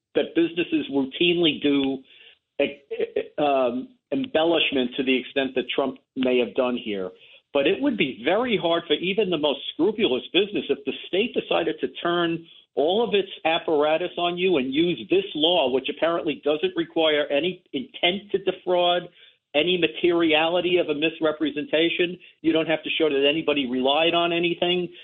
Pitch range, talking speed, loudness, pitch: 145-185 Hz, 160 wpm, -23 LUFS, 170 Hz